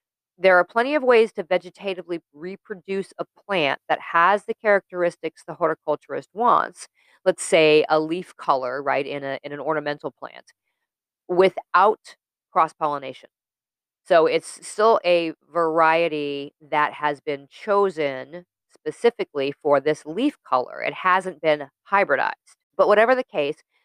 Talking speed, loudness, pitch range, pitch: 135 wpm, -22 LUFS, 150-195 Hz, 170 Hz